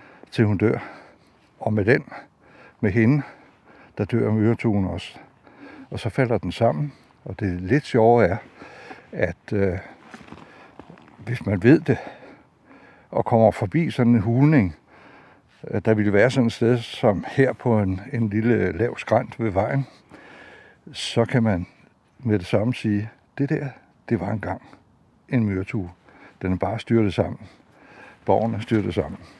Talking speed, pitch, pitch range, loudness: 150 wpm, 115 Hz, 105-120 Hz, -22 LUFS